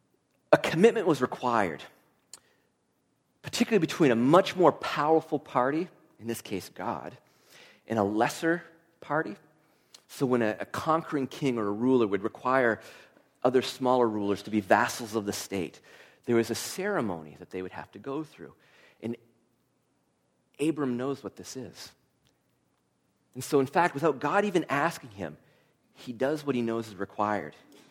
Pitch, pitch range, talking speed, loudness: 125 Hz, 110-145 Hz, 155 wpm, -28 LUFS